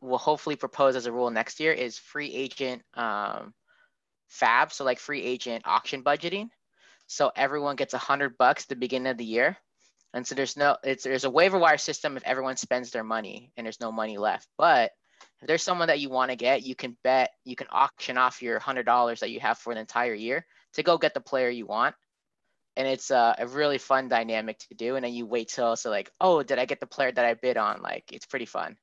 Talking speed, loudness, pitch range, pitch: 235 wpm, -27 LUFS, 120-140 Hz, 130 Hz